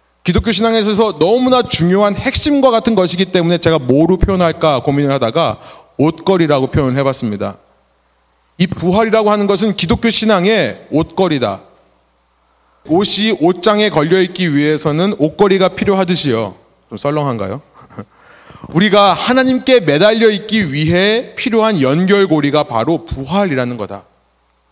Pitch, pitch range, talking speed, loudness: 175 Hz, 140-210 Hz, 320 characters per minute, -13 LUFS